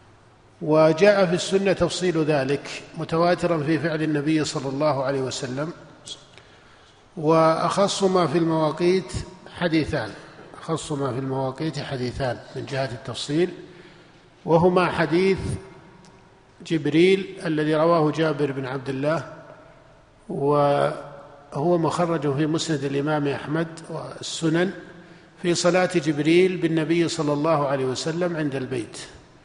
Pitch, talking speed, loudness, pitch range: 155 Hz, 105 wpm, -23 LUFS, 140-175 Hz